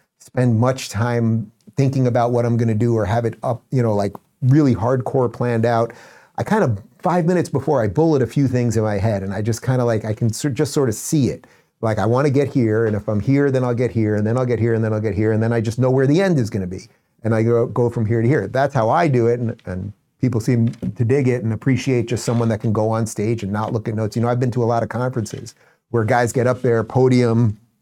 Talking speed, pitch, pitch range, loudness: 285 wpm, 120 Hz, 110-130 Hz, -19 LUFS